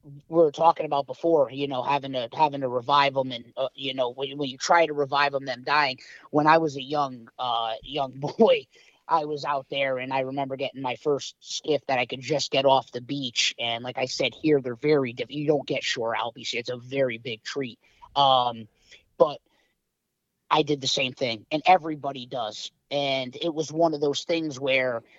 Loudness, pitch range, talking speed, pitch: -25 LUFS, 130-150 Hz, 215 wpm, 140 Hz